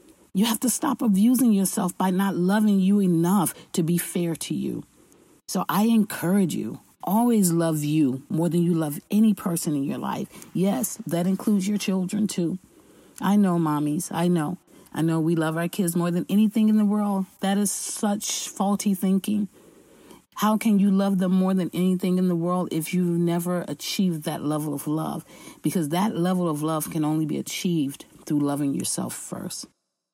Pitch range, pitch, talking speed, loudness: 165-205 Hz, 185 Hz, 185 wpm, -24 LUFS